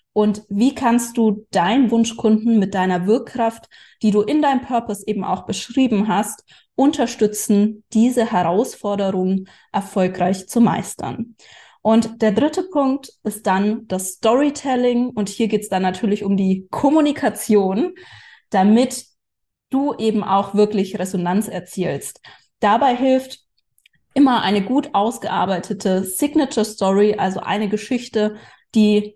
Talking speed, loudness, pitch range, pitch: 125 wpm, -19 LUFS, 200-240 Hz, 215 Hz